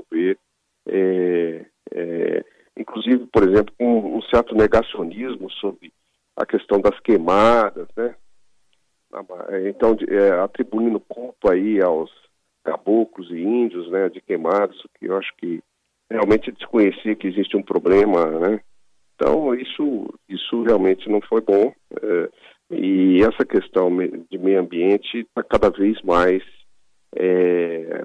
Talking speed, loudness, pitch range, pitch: 125 wpm, -20 LUFS, 90-115 Hz, 100 Hz